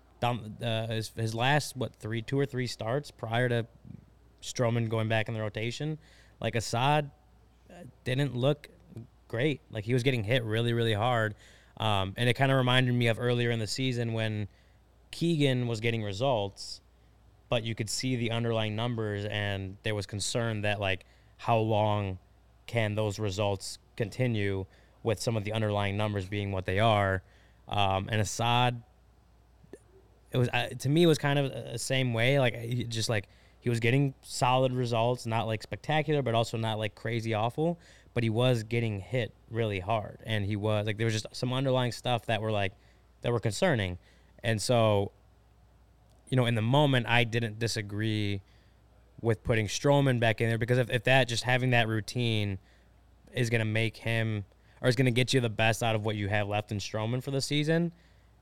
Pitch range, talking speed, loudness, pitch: 105-125 Hz, 185 wpm, -30 LUFS, 115 Hz